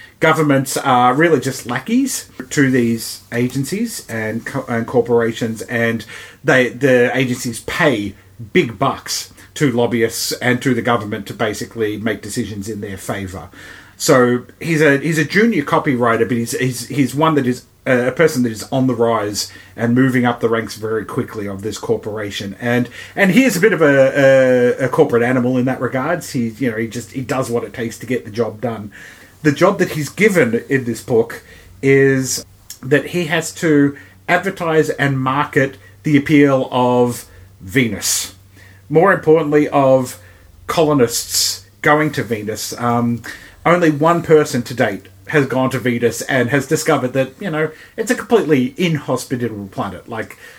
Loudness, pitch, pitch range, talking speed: -16 LUFS, 125 Hz, 115-145 Hz, 165 wpm